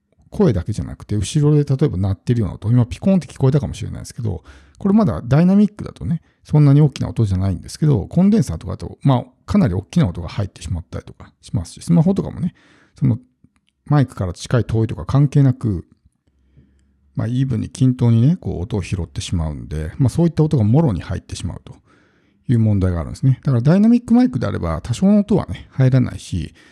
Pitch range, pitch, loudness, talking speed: 95-150 Hz, 120 Hz, -18 LUFS, 460 characters per minute